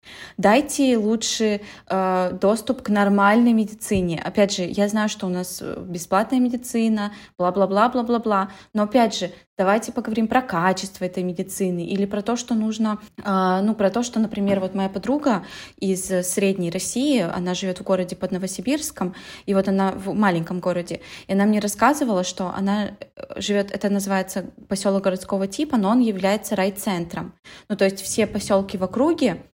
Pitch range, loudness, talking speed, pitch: 190-220 Hz, -22 LUFS, 170 wpm, 200 Hz